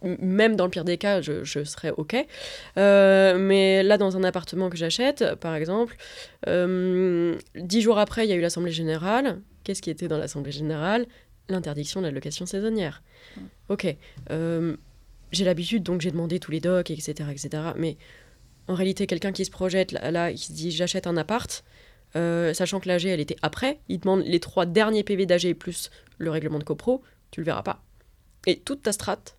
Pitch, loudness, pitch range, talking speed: 180 Hz, -25 LUFS, 160-195 Hz, 190 wpm